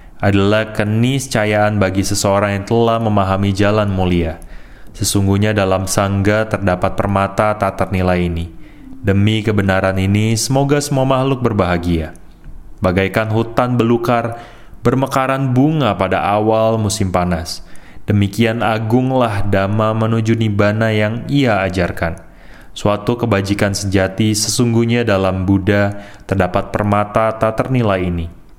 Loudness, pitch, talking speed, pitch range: -16 LUFS, 105 Hz, 110 wpm, 95-115 Hz